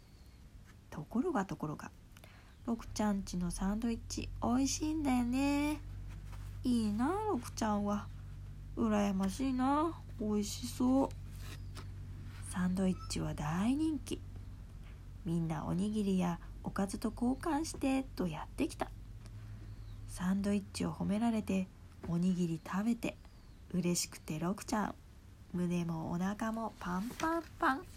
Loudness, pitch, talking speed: -36 LUFS, 185 Hz, 260 characters per minute